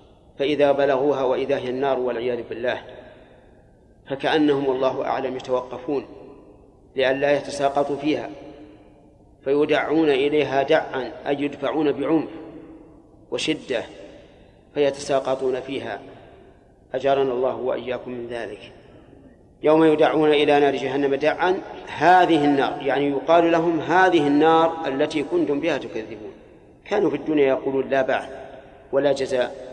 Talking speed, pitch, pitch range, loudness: 105 wpm, 140 Hz, 130-150 Hz, -21 LUFS